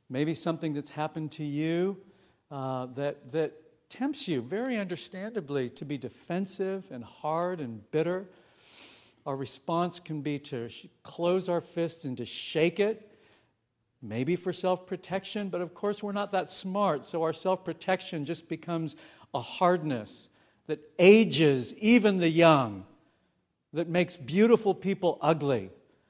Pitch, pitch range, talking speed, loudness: 165 Hz, 145-185 Hz, 145 wpm, -29 LUFS